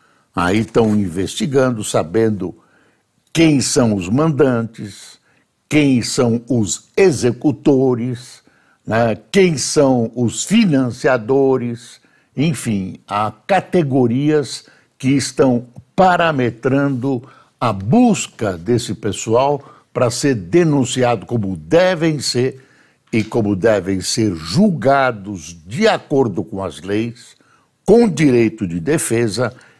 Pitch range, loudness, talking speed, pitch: 110-145 Hz, -16 LUFS, 95 wpm, 125 Hz